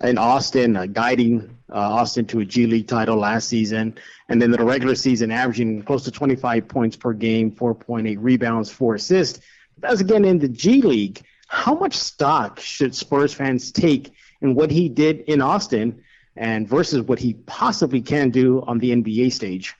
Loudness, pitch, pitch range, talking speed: -20 LUFS, 120 Hz, 115-135 Hz, 185 wpm